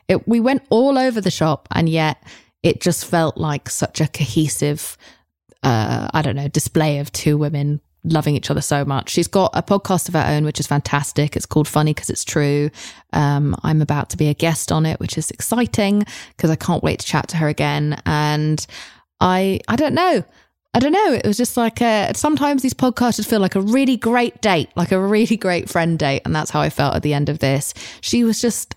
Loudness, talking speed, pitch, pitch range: -18 LUFS, 220 wpm, 155 Hz, 145-215 Hz